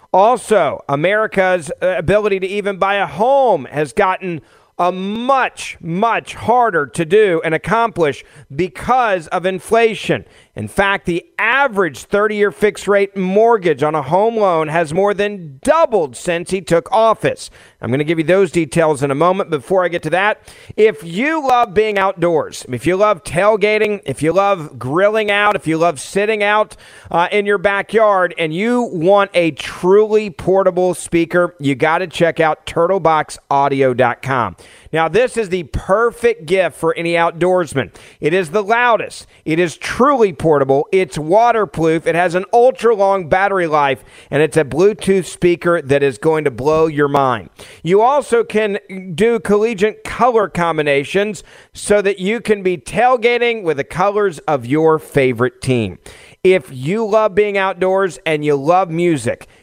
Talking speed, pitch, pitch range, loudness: 160 wpm, 185 Hz, 160-210 Hz, -15 LUFS